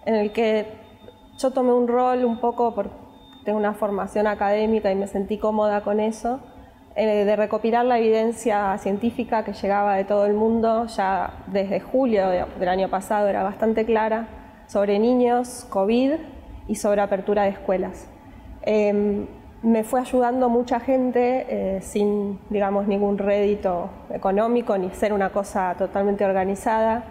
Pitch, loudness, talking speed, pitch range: 215 Hz, -22 LUFS, 150 wpm, 200-230 Hz